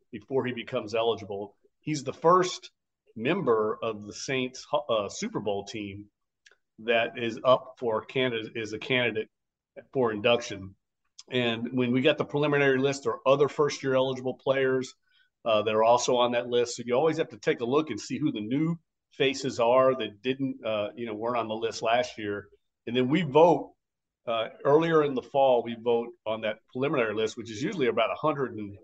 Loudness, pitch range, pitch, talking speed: -27 LUFS, 110-135 Hz, 120 Hz, 190 wpm